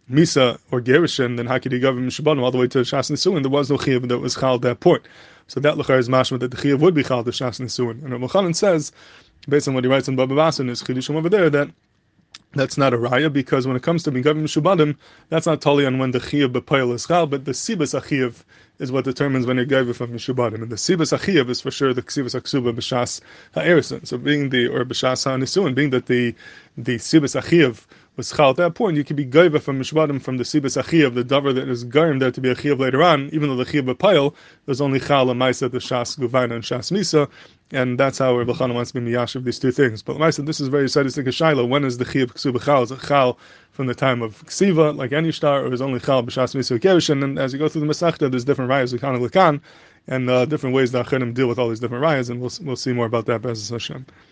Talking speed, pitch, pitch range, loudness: 245 wpm, 130 Hz, 125-145 Hz, -20 LUFS